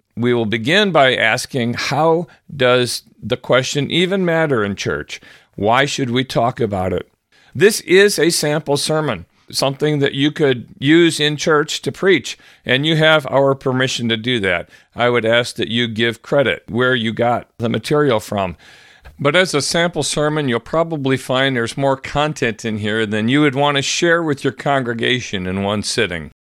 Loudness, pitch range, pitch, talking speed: -16 LUFS, 115-150 Hz, 135 Hz, 180 wpm